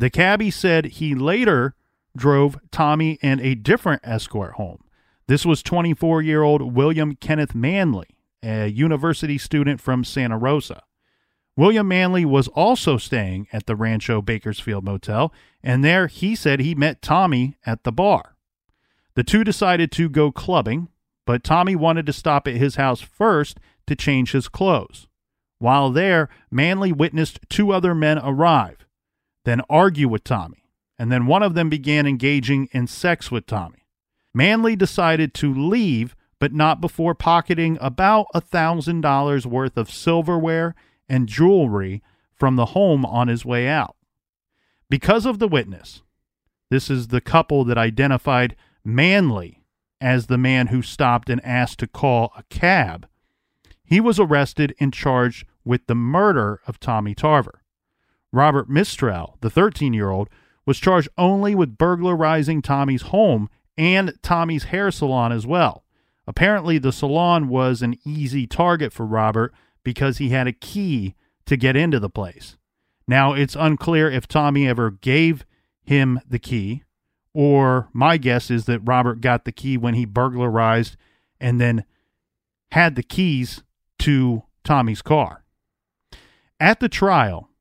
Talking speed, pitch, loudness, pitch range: 150 wpm, 140 Hz, -19 LUFS, 120-165 Hz